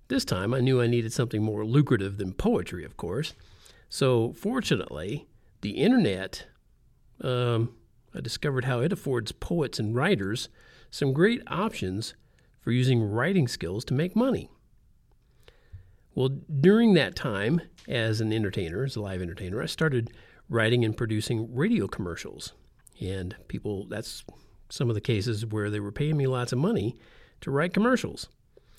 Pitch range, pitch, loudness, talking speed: 105-140 Hz, 120 Hz, -27 LUFS, 150 wpm